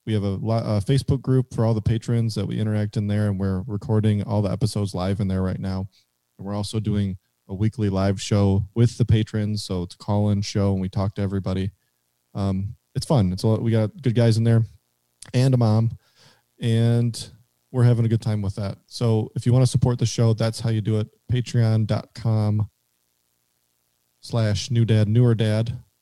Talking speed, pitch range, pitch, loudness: 210 wpm, 100-115 Hz, 110 Hz, -23 LUFS